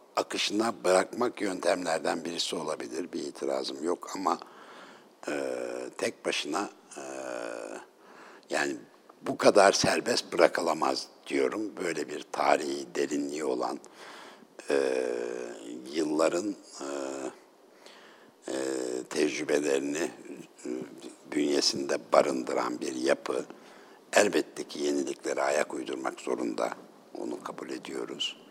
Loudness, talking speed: -30 LUFS, 85 wpm